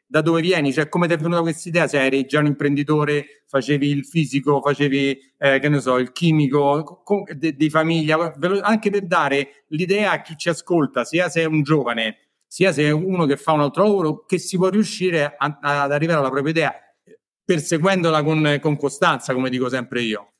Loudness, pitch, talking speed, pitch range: -20 LUFS, 150 Hz, 205 wpm, 140-170 Hz